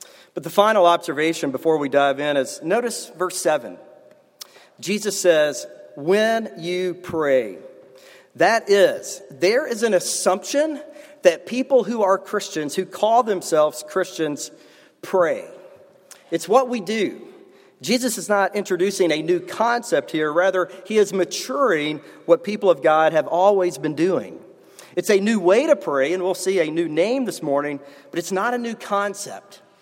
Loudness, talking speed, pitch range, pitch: -20 LUFS, 155 wpm, 165-225 Hz, 185 Hz